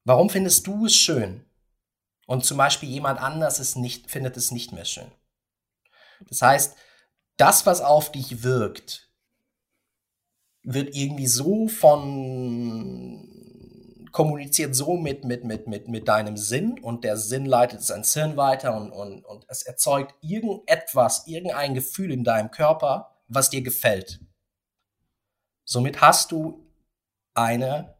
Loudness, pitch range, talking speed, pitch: -22 LUFS, 115-150 Hz, 135 wpm, 130 Hz